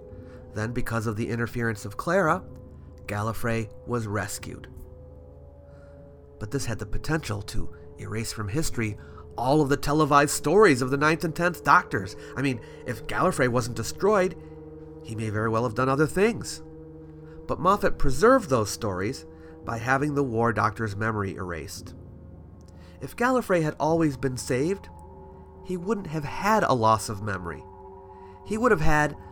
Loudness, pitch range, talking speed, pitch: -25 LUFS, 95-150 Hz, 150 wpm, 115 Hz